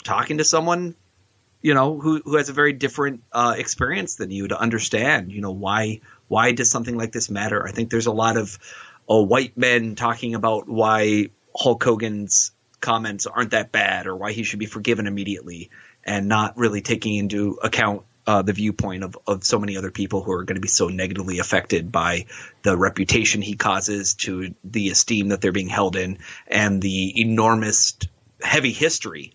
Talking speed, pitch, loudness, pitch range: 185 wpm, 105 Hz, -21 LUFS, 100-115 Hz